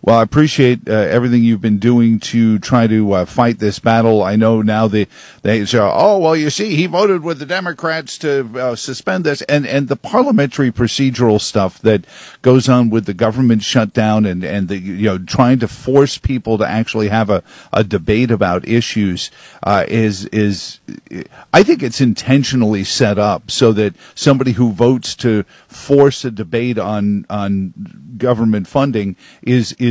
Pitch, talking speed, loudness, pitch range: 115 Hz, 175 wpm, -14 LUFS, 105-130 Hz